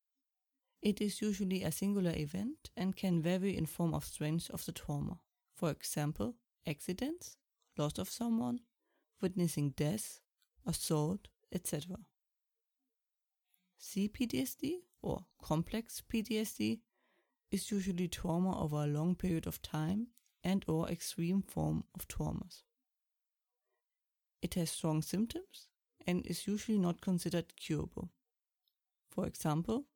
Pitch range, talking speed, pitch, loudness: 165-225 Hz, 110 wpm, 185 Hz, -38 LUFS